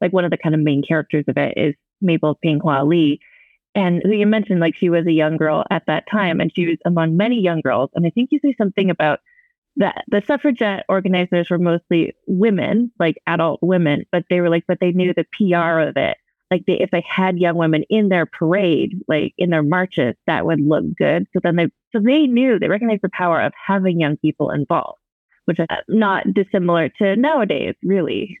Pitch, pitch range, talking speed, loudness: 180 Hz, 165-200 Hz, 215 wpm, -18 LUFS